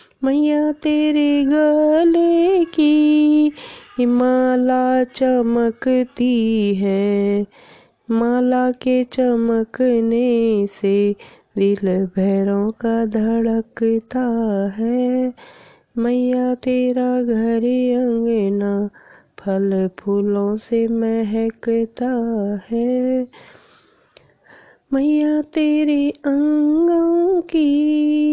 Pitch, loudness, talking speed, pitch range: 245 Hz, -18 LUFS, 60 wpm, 225-290 Hz